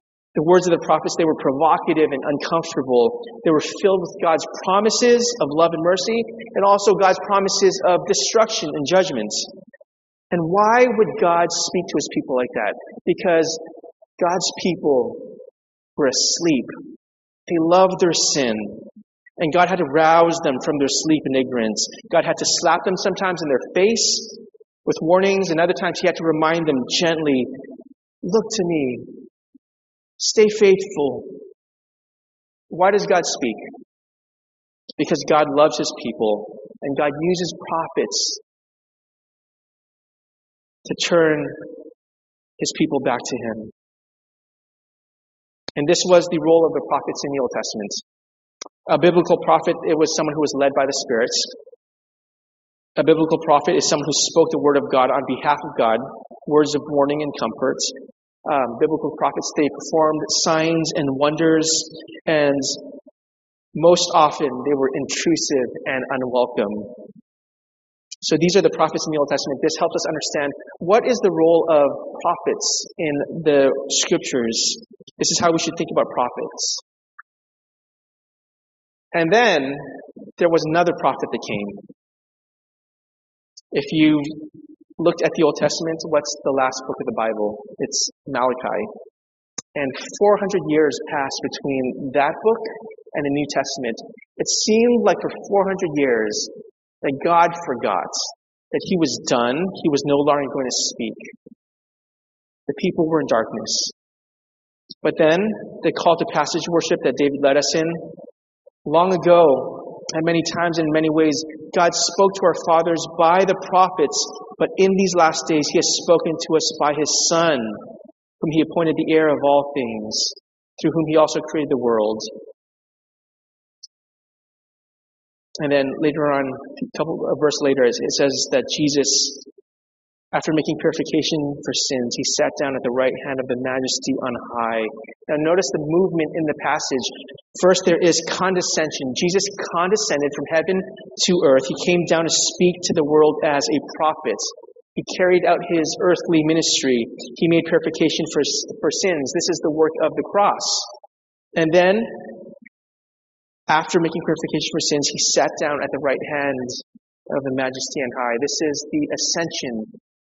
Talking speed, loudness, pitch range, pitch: 155 wpm, -19 LUFS, 145-185 Hz, 160 Hz